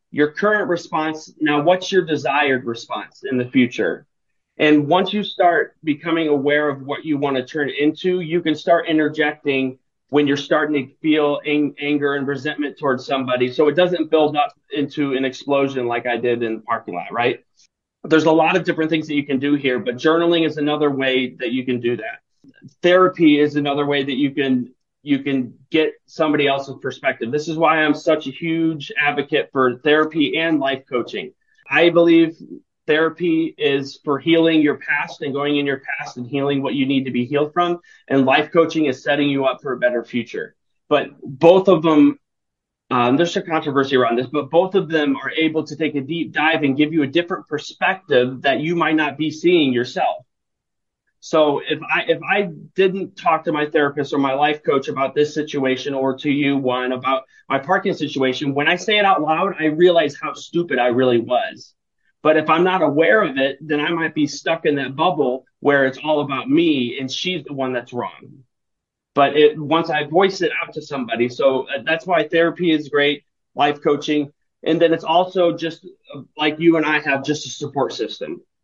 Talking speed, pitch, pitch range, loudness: 200 wpm, 150 Hz, 135-165 Hz, -19 LUFS